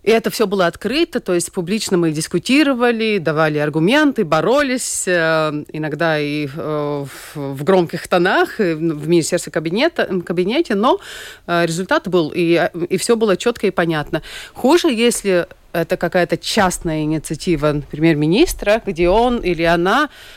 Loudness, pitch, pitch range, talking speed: -17 LUFS, 175 Hz, 160-220 Hz, 130 wpm